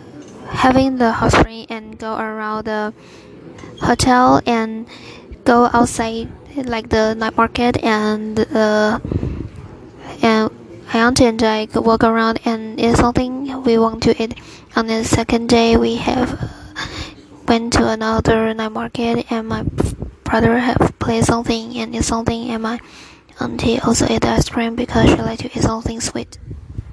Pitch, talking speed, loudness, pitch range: 230 Hz, 150 wpm, -17 LUFS, 220-235 Hz